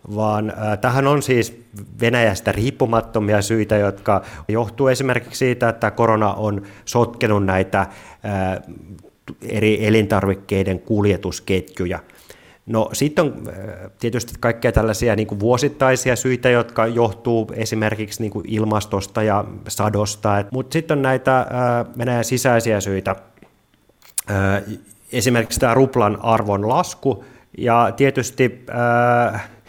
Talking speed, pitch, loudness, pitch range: 115 wpm, 110 Hz, -19 LUFS, 105-120 Hz